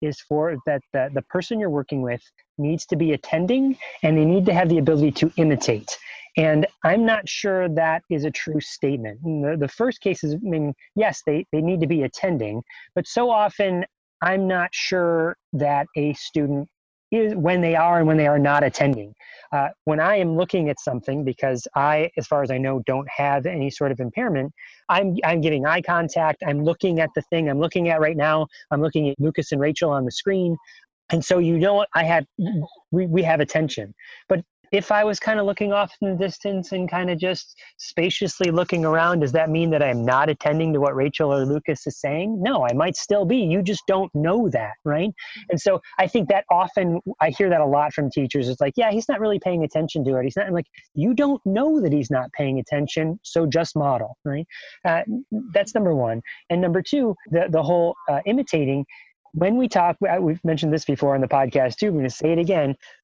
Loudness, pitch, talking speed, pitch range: -22 LUFS, 160 Hz, 220 wpm, 145-185 Hz